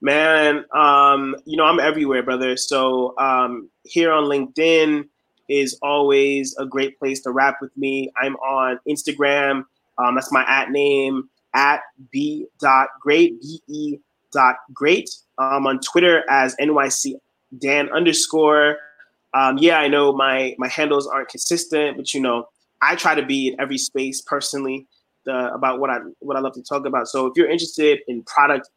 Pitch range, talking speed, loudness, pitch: 130-150 Hz, 165 wpm, -18 LUFS, 140 Hz